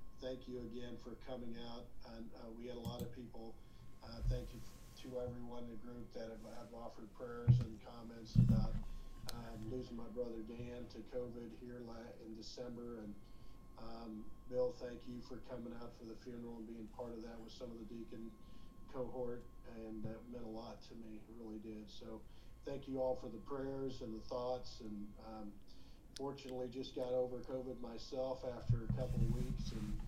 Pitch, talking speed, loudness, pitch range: 120 Hz, 190 wpm, -46 LUFS, 115-125 Hz